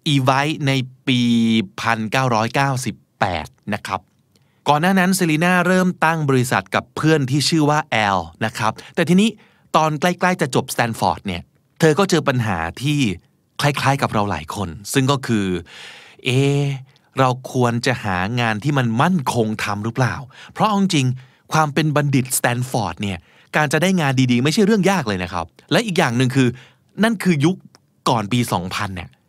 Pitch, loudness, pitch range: 135 Hz, -19 LUFS, 115-155 Hz